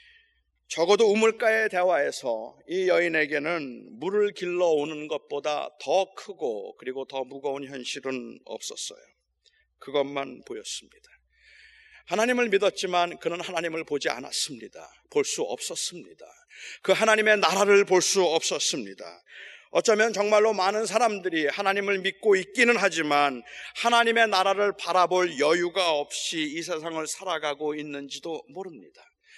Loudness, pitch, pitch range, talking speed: -25 LUFS, 190 Hz, 160-230 Hz, 305 characters per minute